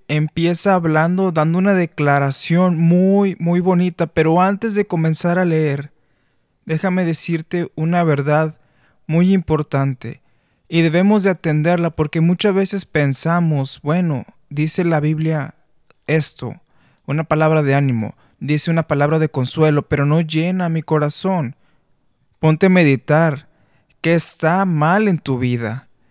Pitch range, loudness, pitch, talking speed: 150-175 Hz, -17 LUFS, 160 Hz, 130 wpm